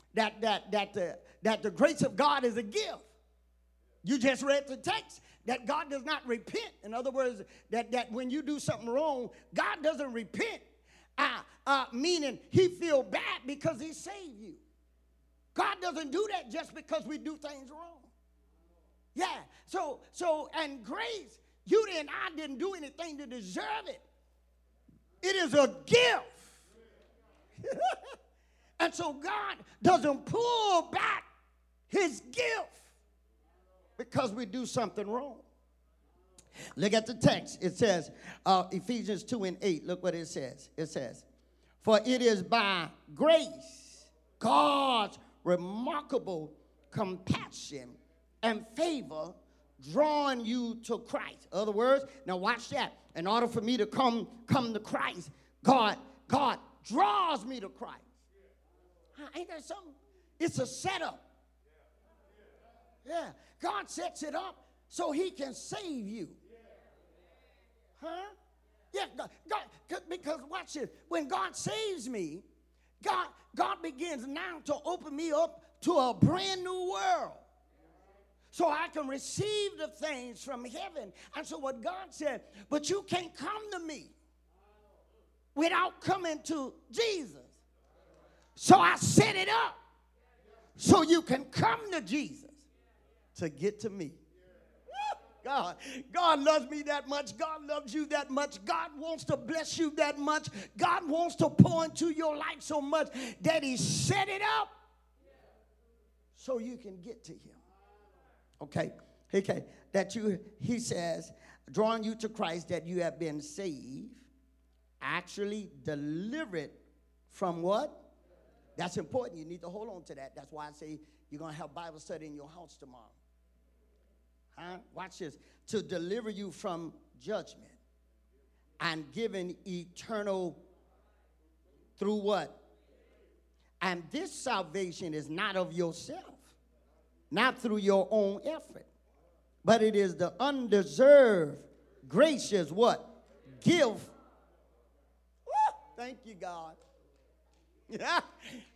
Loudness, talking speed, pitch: -32 LUFS, 135 wpm, 250 Hz